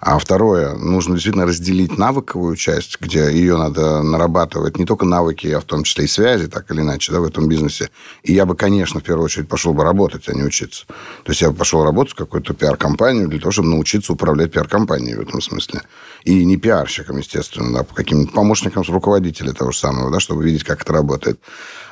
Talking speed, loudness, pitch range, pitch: 210 wpm, -16 LUFS, 75-90 Hz, 80 Hz